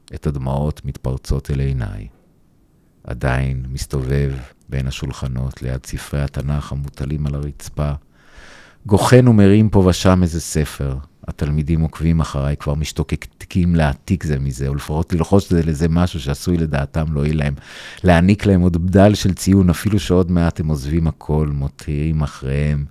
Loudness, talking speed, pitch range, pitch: -18 LUFS, 140 wpm, 70-90 Hz, 75 Hz